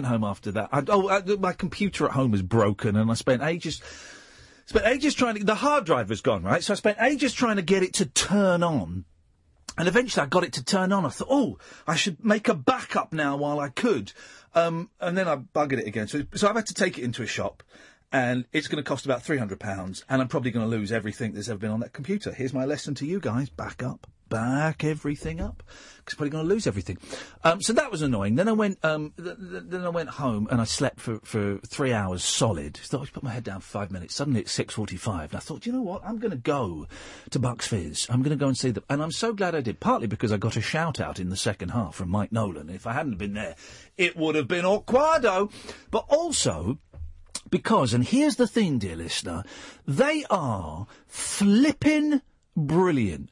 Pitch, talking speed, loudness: 145 Hz, 240 wpm, -26 LUFS